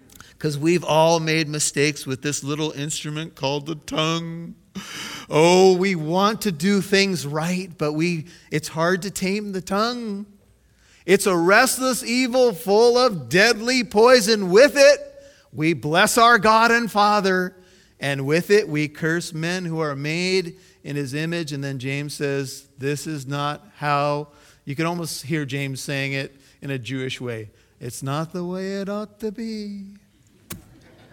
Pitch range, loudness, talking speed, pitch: 145-200 Hz, -20 LUFS, 160 wpm, 165 Hz